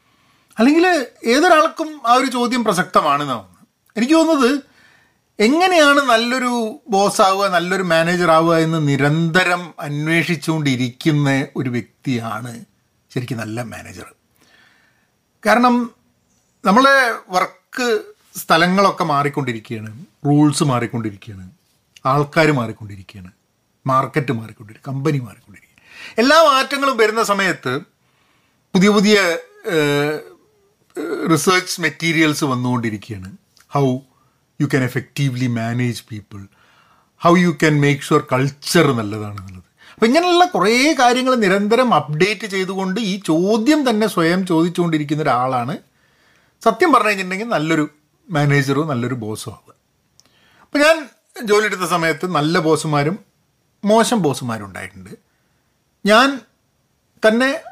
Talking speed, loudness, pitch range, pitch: 95 wpm, -16 LUFS, 130-225 Hz, 165 Hz